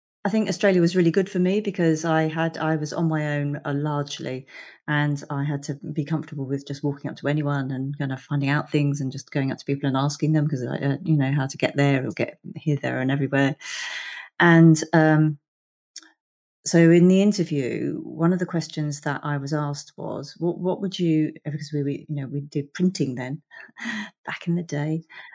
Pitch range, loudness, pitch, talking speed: 145-165 Hz, -23 LUFS, 150 Hz, 215 wpm